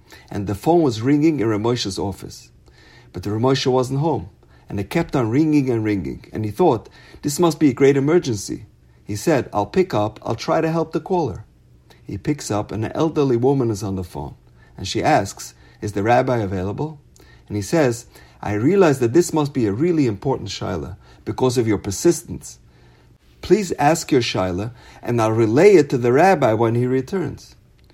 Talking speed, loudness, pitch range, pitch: 190 wpm, -19 LUFS, 105-150 Hz, 120 Hz